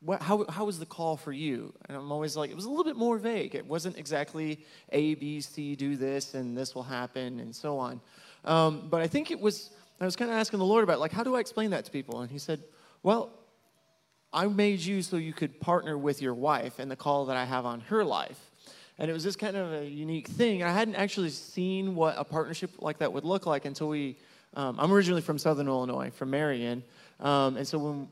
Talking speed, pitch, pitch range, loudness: 245 wpm, 155 Hz, 140-195 Hz, -31 LUFS